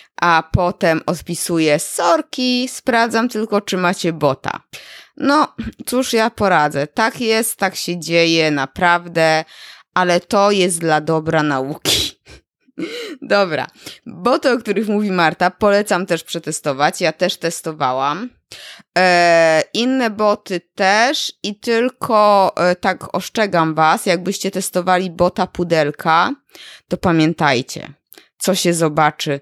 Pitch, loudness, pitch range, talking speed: 180 Hz, -16 LUFS, 165-220 Hz, 115 wpm